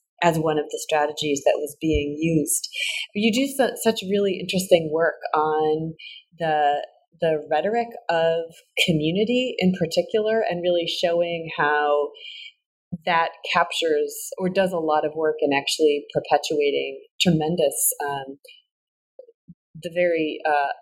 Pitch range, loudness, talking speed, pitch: 155-230 Hz, -22 LUFS, 125 wpm, 170 Hz